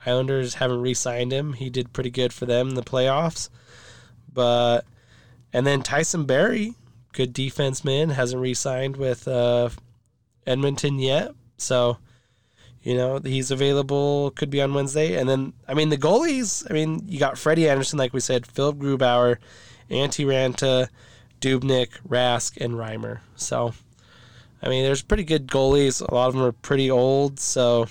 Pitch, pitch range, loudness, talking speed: 130 Hz, 120-140 Hz, -23 LUFS, 155 wpm